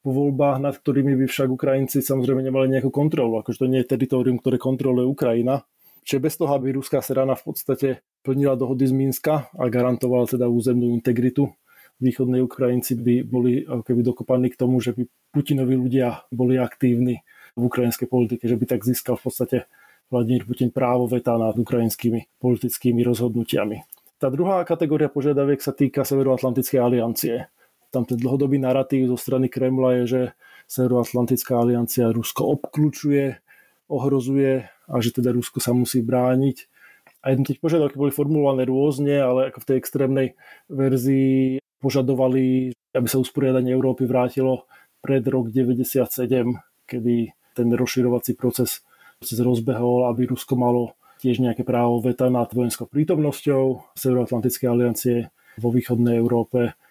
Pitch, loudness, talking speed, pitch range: 130 Hz, -22 LUFS, 140 wpm, 125-135 Hz